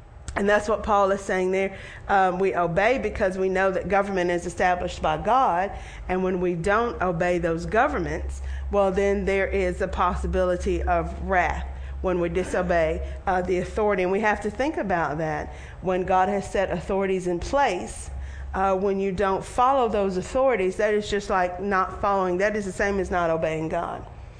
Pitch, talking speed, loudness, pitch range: 190 Hz, 185 wpm, -24 LUFS, 180-200 Hz